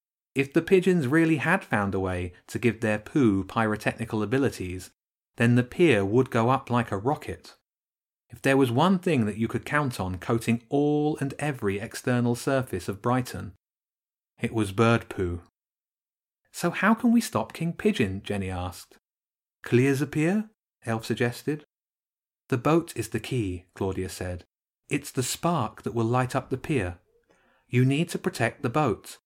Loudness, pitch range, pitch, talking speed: -26 LUFS, 105-145 Hz, 120 Hz, 165 wpm